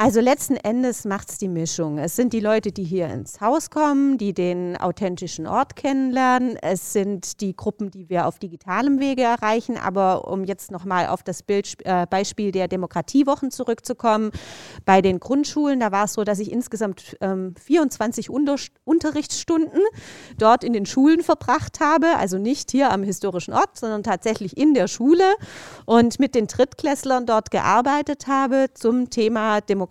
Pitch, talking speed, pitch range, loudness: 220 Hz, 170 wpm, 190-270 Hz, -21 LUFS